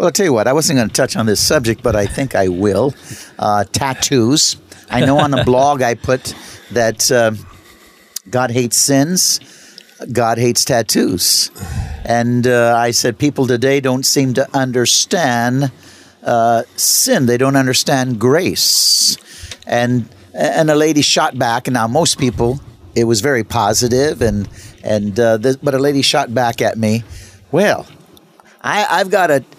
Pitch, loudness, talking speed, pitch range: 120 Hz, -14 LUFS, 165 wpm, 115-135 Hz